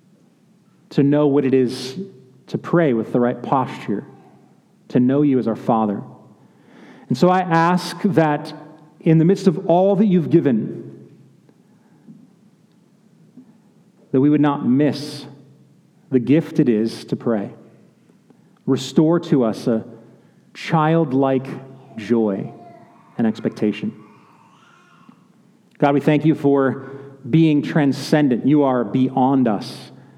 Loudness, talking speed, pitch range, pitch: -18 LUFS, 120 wpm, 130-180 Hz, 150 Hz